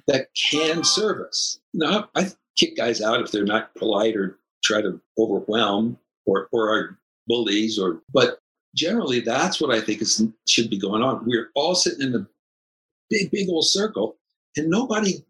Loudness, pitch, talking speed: -22 LUFS, 125 Hz, 170 wpm